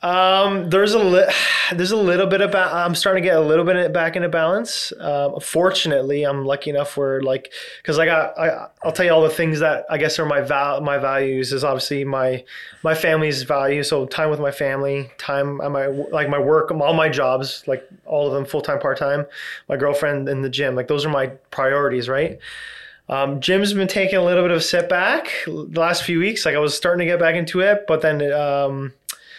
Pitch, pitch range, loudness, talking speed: 150 Hz, 140-175 Hz, -19 LUFS, 225 wpm